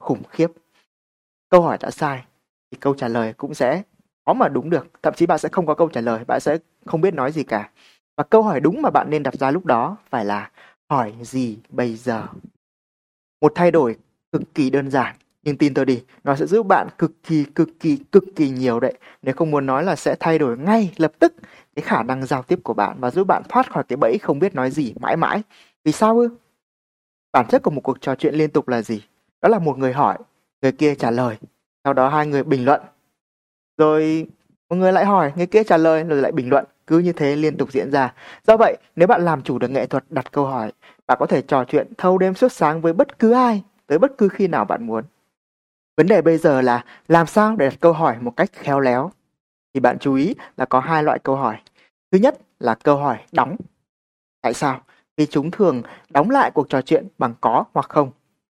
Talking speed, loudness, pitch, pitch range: 235 wpm, -19 LUFS, 150 Hz, 130-170 Hz